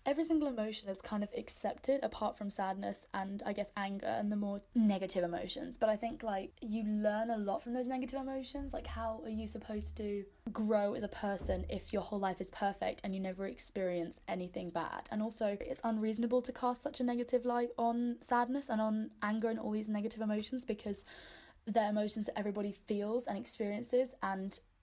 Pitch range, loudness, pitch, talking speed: 200-240 Hz, -37 LUFS, 215 Hz, 200 wpm